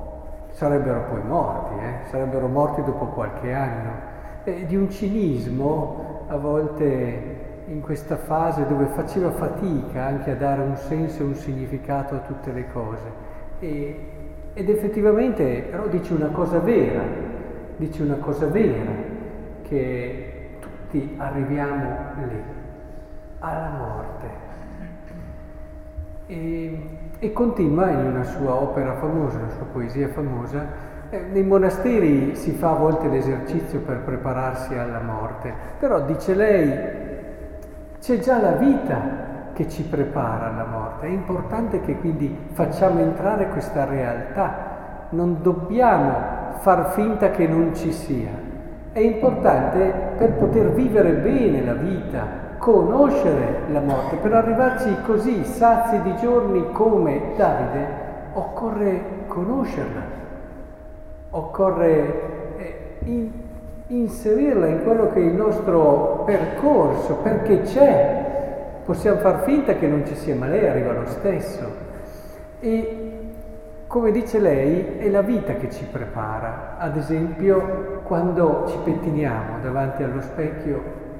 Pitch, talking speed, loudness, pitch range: 155 Hz, 125 wpm, -22 LUFS, 140-195 Hz